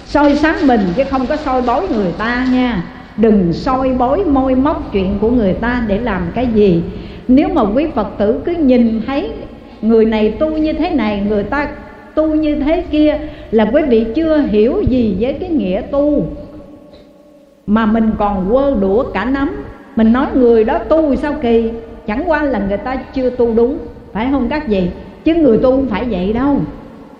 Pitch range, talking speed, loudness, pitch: 220-285 Hz, 190 wpm, -14 LUFS, 255 Hz